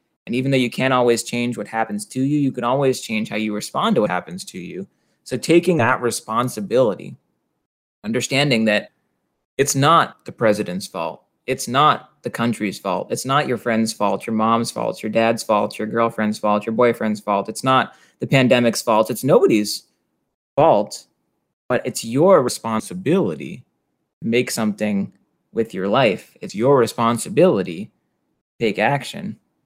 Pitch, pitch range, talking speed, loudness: 115 Hz, 110-130 Hz, 160 wpm, -19 LUFS